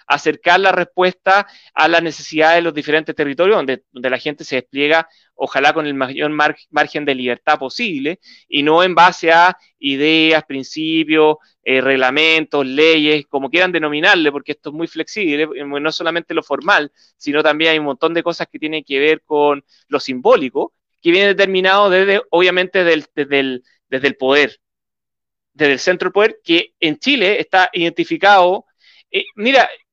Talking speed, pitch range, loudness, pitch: 170 wpm, 145-180 Hz, -15 LUFS, 155 Hz